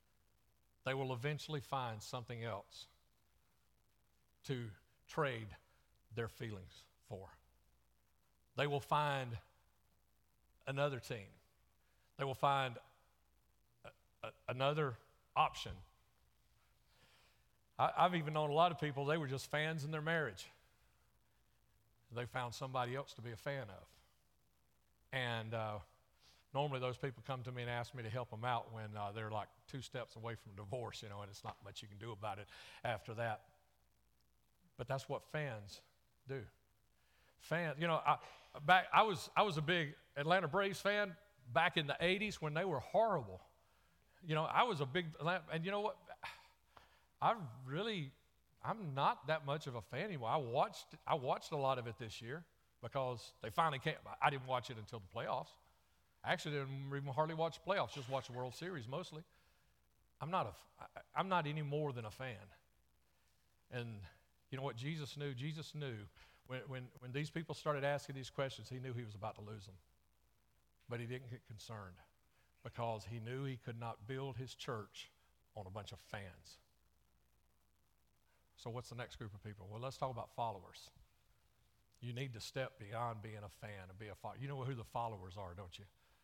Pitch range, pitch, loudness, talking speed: 105-145 Hz, 125 Hz, -41 LUFS, 175 wpm